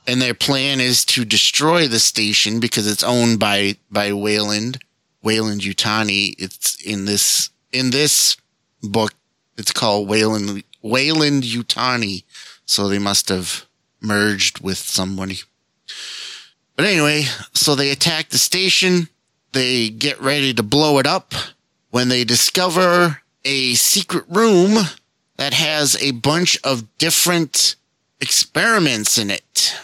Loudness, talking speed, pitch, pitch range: -16 LUFS, 125 wpm, 125 Hz, 105-150 Hz